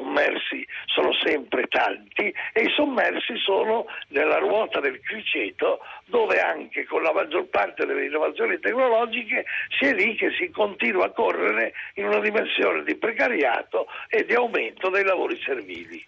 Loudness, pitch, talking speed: -23 LUFS, 370 Hz, 155 wpm